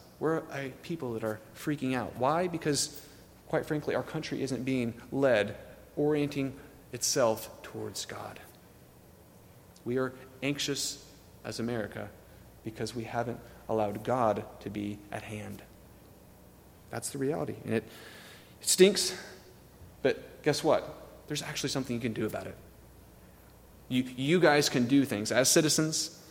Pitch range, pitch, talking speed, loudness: 110-145 Hz, 125 Hz, 135 wpm, -31 LUFS